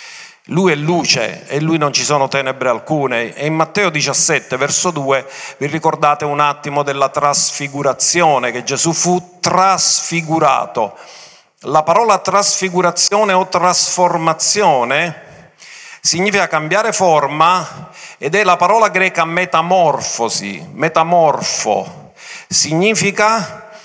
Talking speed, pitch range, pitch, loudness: 105 wpm, 145-190 Hz, 170 Hz, -14 LUFS